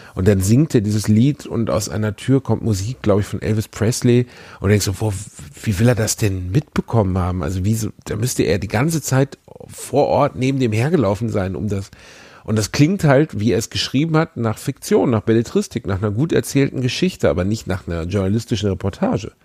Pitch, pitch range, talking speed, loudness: 110 Hz, 100-130 Hz, 210 wpm, -19 LUFS